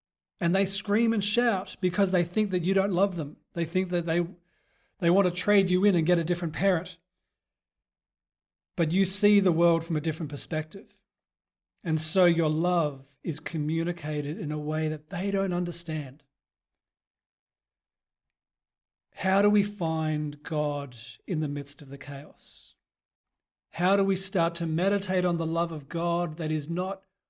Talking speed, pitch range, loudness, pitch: 165 wpm, 155-190 Hz, -27 LUFS, 170 Hz